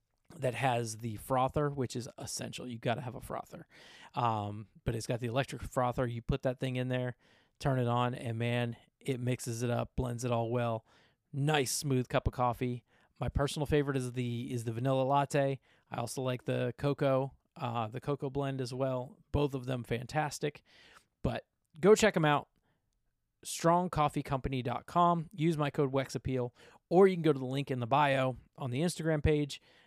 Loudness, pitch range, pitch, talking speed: -33 LUFS, 125-145 Hz, 130 Hz, 185 wpm